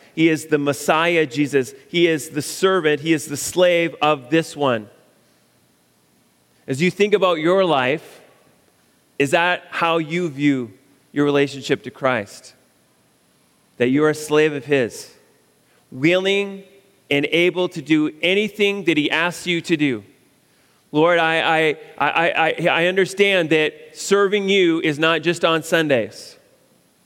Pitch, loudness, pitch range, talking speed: 160 Hz, -19 LUFS, 145-175 Hz, 145 wpm